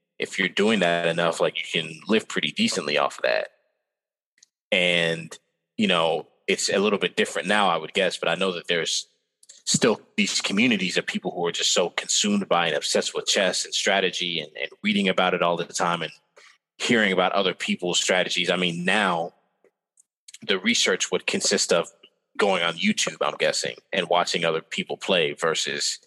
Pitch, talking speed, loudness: 210 Hz, 185 wpm, -23 LUFS